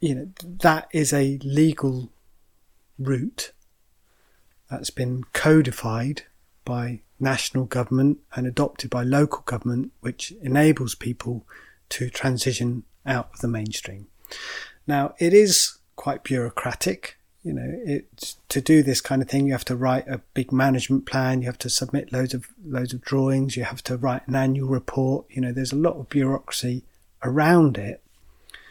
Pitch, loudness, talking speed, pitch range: 130 Hz, -23 LUFS, 155 wpm, 125-140 Hz